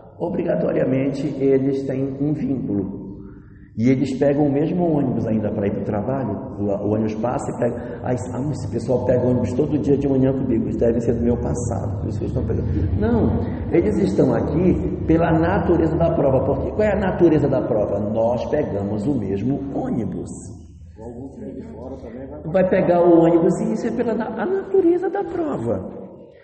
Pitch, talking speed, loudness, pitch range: 130 Hz, 155 wpm, -20 LUFS, 110-160 Hz